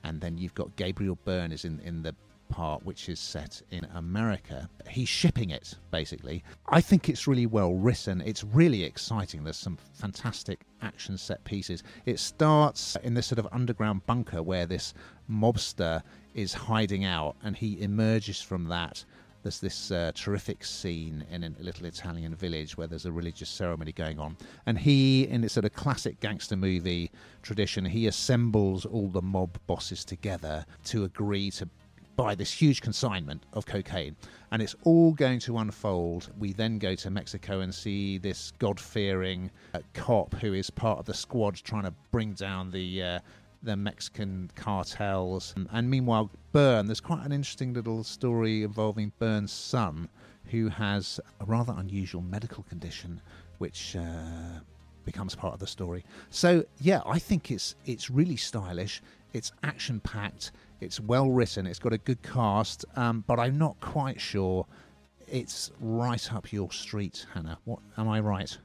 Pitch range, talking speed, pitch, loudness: 90-115 Hz, 165 wpm, 100 Hz, -30 LUFS